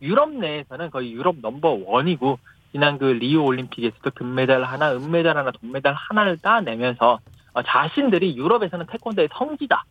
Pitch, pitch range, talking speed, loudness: 145 Hz, 125-180 Hz, 375 characters per minute, -21 LUFS